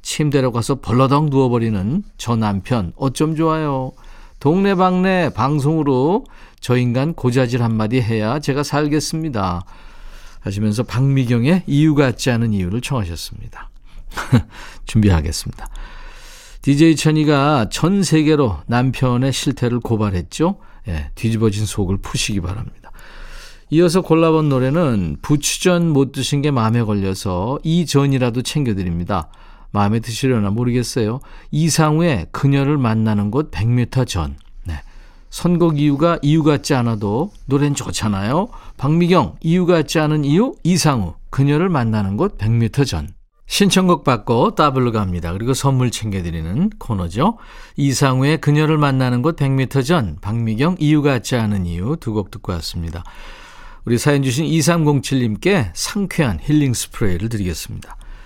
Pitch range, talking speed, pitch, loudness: 110-155 Hz, 300 characters per minute, 130 Hz, -17 LUFS